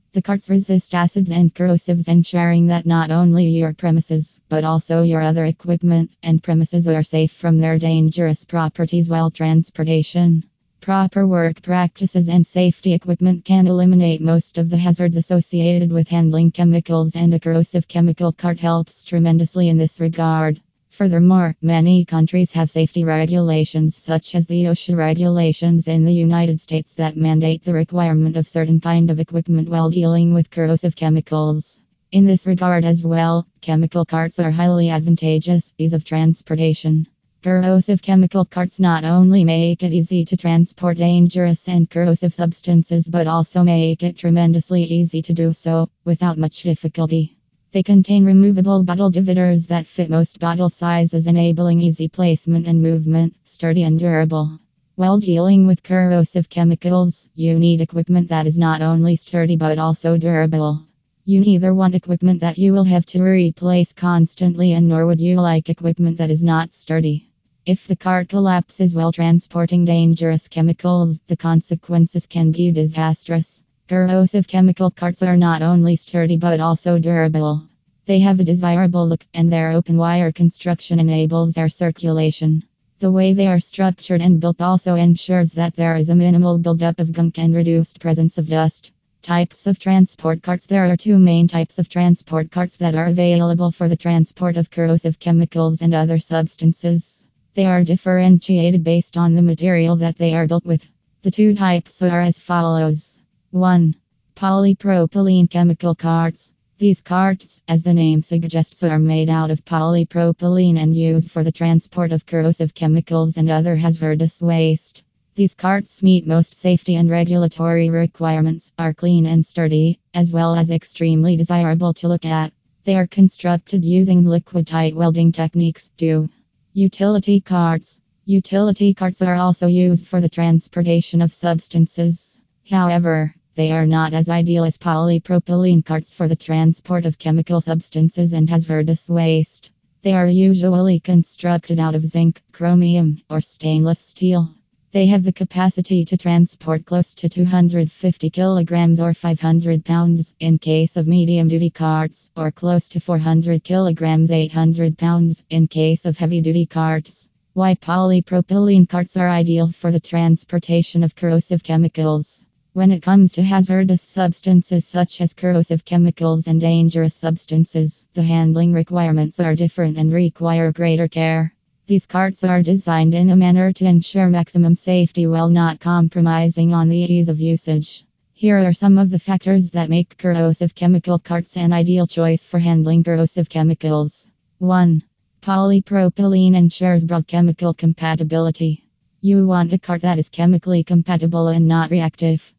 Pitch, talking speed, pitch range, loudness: 170 Hz, 155 wpm, 165-175 Hz, -16 LUFS